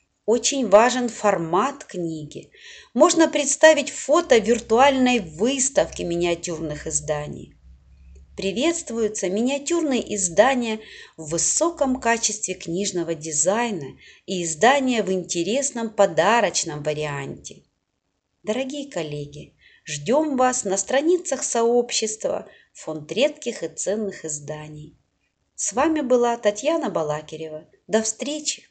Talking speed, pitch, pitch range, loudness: 90 wpm, 210 Hz, 160-260 Hz, -21 LUFS